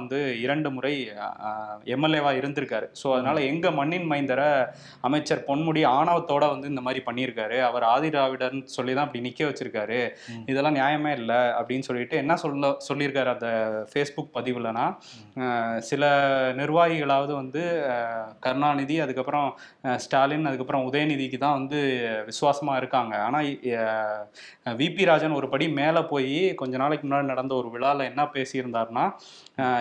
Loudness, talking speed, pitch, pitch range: -26 LUFS, 125 wpm, 135 Hz, 125-145 Hz